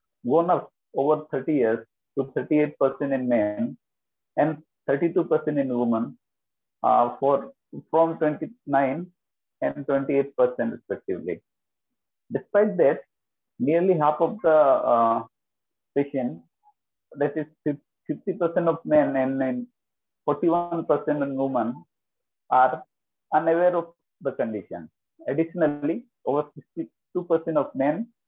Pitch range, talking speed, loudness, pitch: 135-165 Hz, 100 wpm, -25 LUFS, 150 Hz